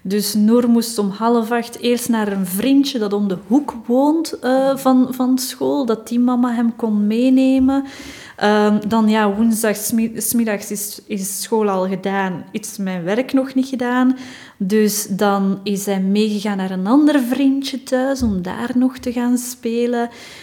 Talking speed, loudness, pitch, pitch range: 165 wpm, -18 LUFS, 230 Hz, 205-255 Hz